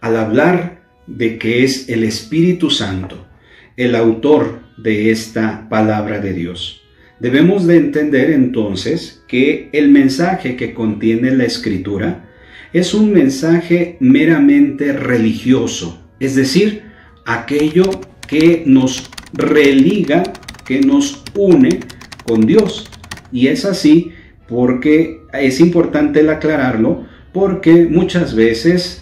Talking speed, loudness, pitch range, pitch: 110 wpm, -13 LUFS, 110-165 Hz, 135 Hz